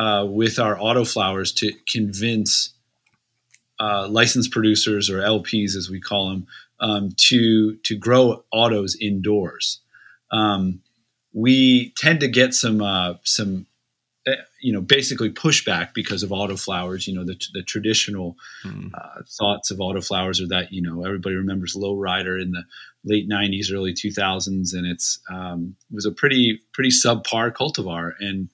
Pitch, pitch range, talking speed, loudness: 105 Hz, 95-115 Hz, 150 wpm, -20 LUFS